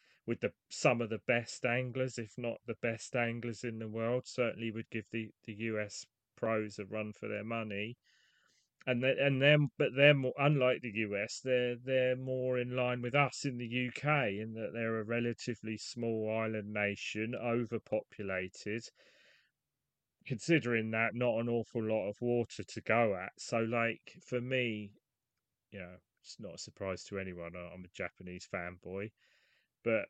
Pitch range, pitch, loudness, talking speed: 110-125 Hz, 115 Hz, -35 LUFS, 165 wpm